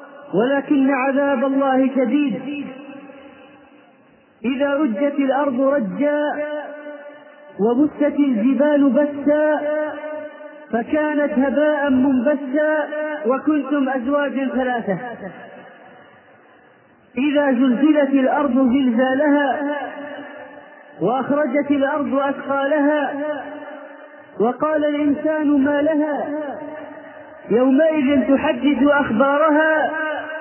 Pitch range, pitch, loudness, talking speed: 270-295 Hz, 285 Hz, -18 LUFS, 60 wpm